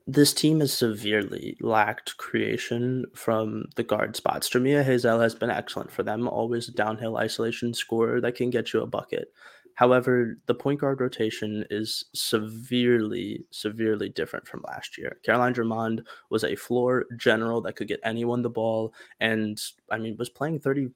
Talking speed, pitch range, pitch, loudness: 170 wpm, 110-125 Hz, 120 Hz, -26 LUFS